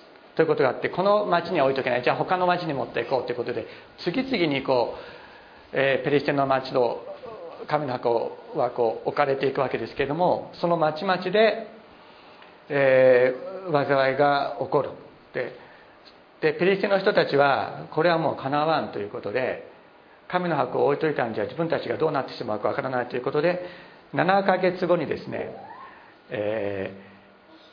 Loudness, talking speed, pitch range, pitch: -24 LUFS, 340 characters per minute, 135-185 Hz, 155 Hz